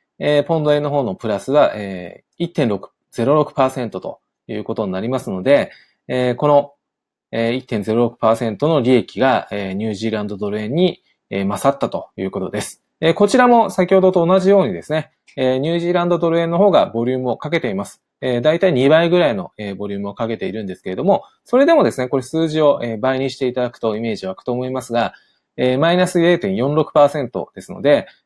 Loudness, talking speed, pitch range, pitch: -17 LUFS, 390 characters per minute, 115-165 Hz, 135 Hz